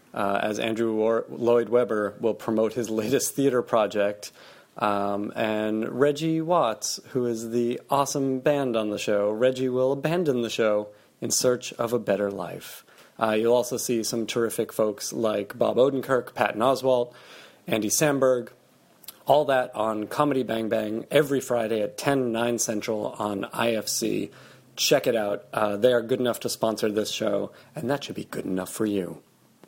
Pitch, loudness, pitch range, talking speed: 115 Hz, -25 LUFS, 110-130 Hz, 170 wpm